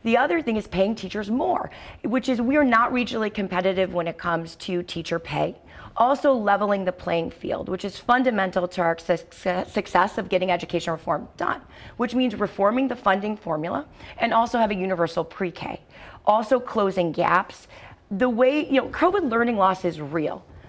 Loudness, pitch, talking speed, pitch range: -24 LUFS, 200 Hz, 175 wpm, 175-240 Hz